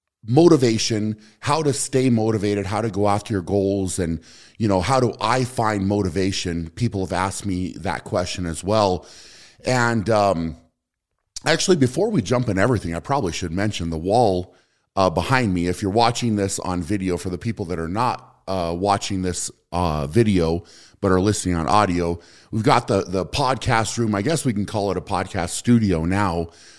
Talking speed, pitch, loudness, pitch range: 185 wpm, 100 Hz, -21 LUFS, 90-115 Hz